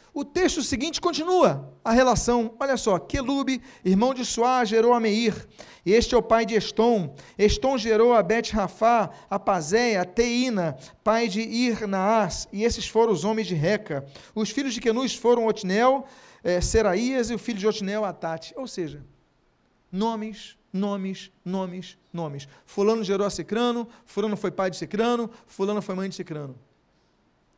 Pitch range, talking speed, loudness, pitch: 190-240 Hz, 155 wpm, -24 LUFS, 220 Hz